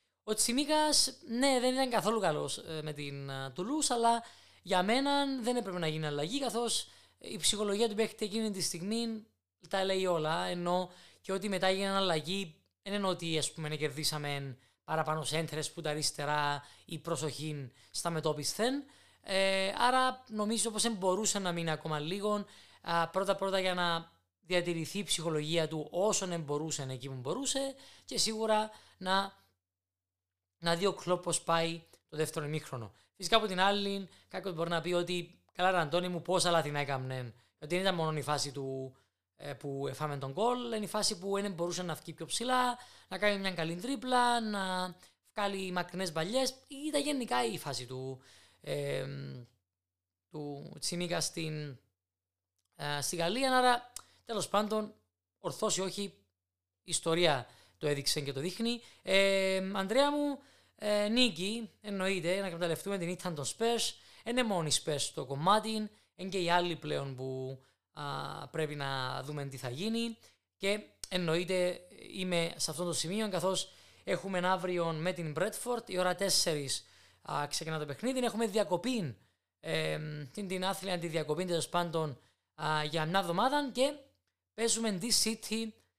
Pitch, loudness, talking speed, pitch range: 180 Hz, -33 LUFS, 155 wpm, 150-210 Hz